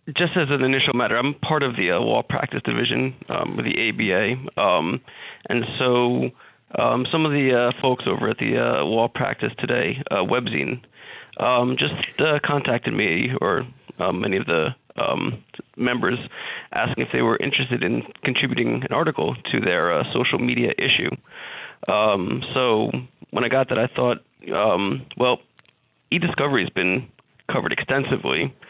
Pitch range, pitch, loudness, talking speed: 120-140 Hz, 130 Hz, -22 LUFS, 160 wpm